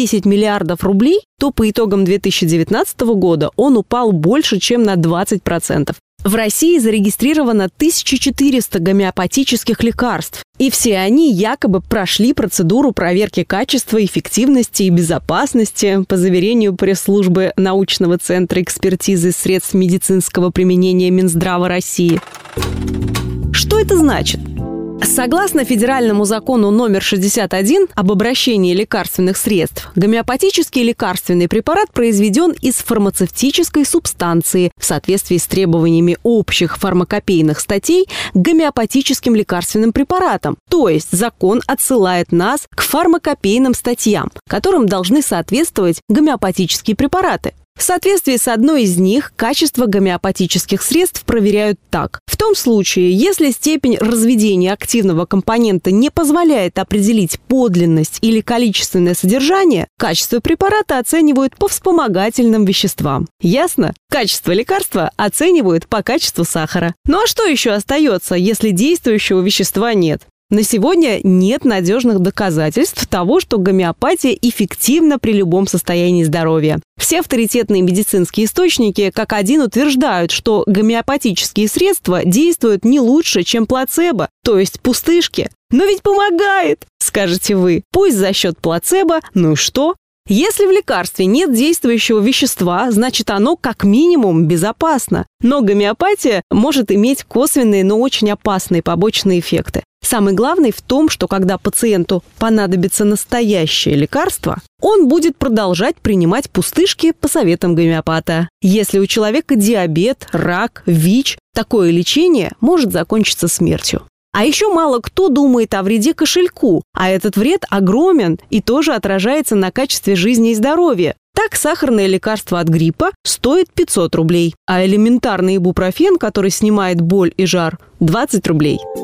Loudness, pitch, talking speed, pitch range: -13 LUFS, 215 Hz, 125 wpm, 185-270 Hz